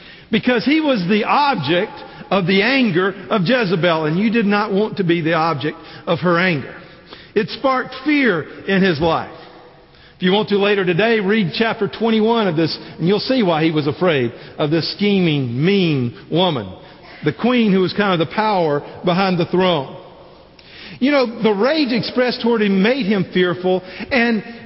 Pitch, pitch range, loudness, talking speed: 190 Hz, 170-220 Hz, -17 LUFS, 180 wpm